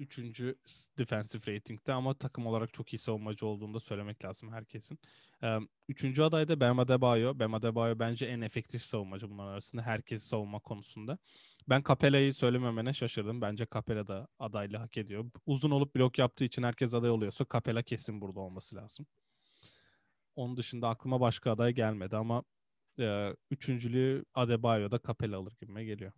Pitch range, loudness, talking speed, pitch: 110-130 Hz, -34 LUFS, 150 wpm, 115 Hz